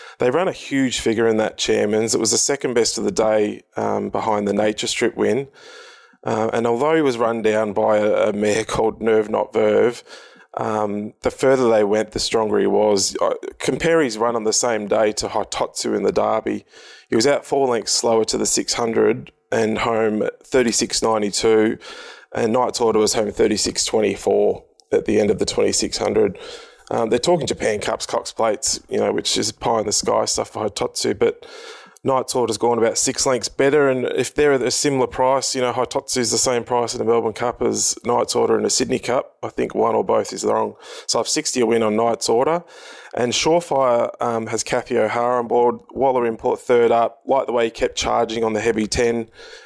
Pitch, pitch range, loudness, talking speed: 120 Hz, 110-160 Hz, -19 LUFS, 205 wpm